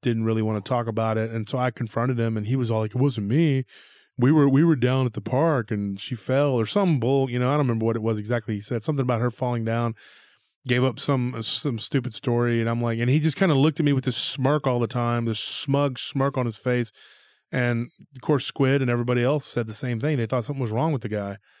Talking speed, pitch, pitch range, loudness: 270 wpm, 125 Hz, 115-140 Hz, -24 LUFS